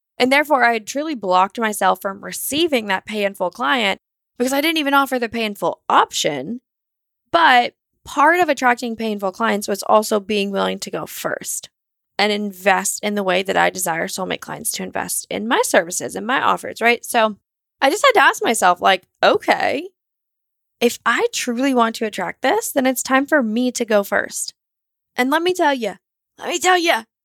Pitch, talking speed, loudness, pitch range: 235 Hz, 185 wpm, -18 LUFS, 205-275 Hz